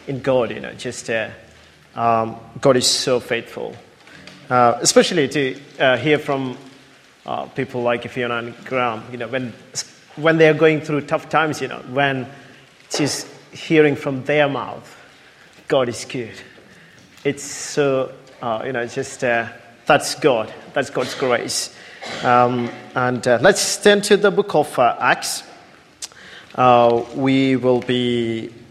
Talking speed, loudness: 145 wpm, -19 LUFS